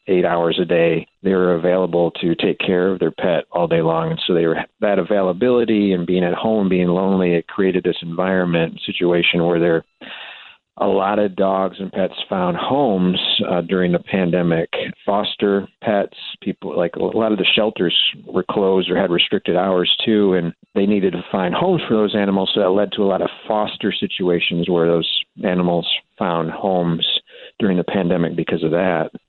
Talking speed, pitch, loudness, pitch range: 190 wpm, 90 Hz, -18 LUFS, 85-95 Hz